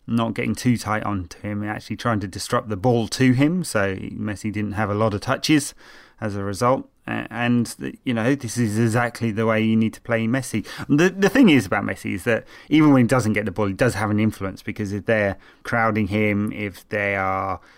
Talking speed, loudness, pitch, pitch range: 225 wpm, -22 LUFS, 110 Hz, 105-120 Hz